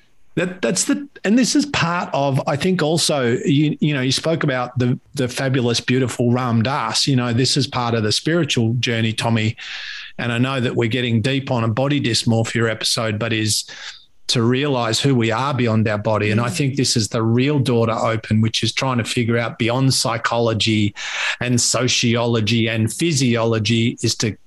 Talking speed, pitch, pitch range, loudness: 195 wpm, 120 Hz, 115-135 Hz, -18 LUFS